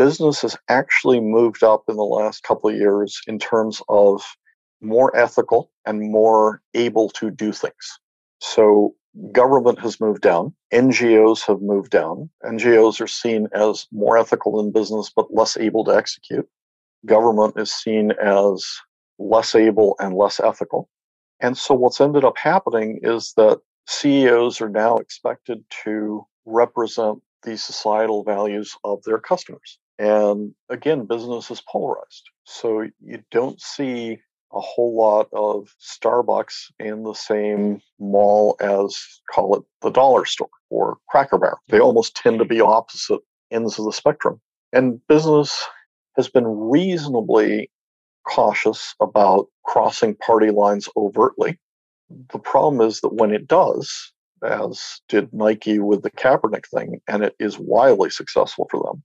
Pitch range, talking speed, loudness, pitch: 105-125 Hz, 145 wpm, -18 LUFS, 110 Hz